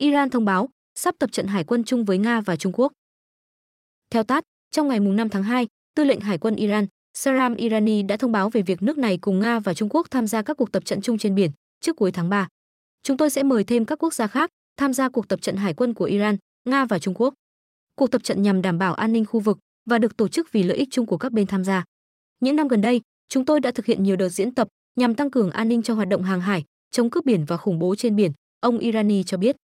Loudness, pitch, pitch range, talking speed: -22 LUFS, 225 Hz, 195-255 Hz, 270 wpm